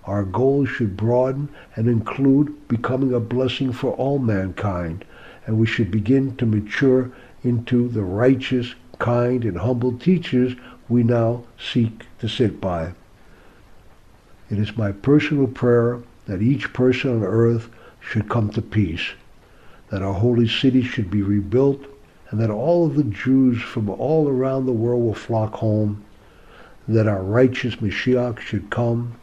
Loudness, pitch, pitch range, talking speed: -21 LUFS, 120 Hz, 110-130 Hz, 150 wpm